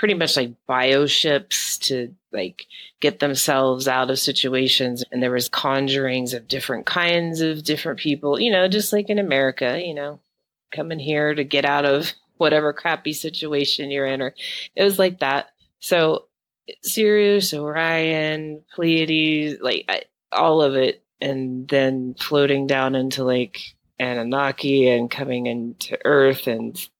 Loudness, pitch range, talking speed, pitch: -20 LUFS, 130-155 Hz, 150 wpm, 140 Hz